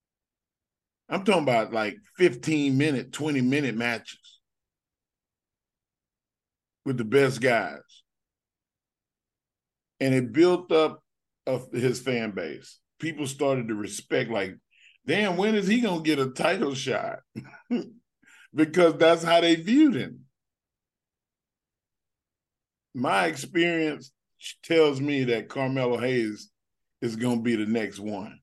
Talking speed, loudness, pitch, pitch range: 120 wpm, -25 LUFS, 135 Hz, 120-160 Hz